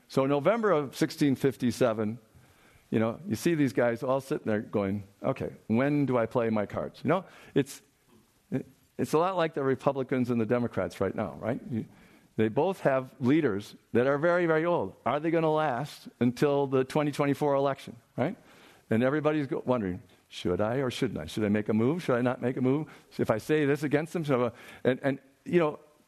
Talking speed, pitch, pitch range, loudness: 200 wpm, 130 Hz, 115-145 Hz, -29 LUFS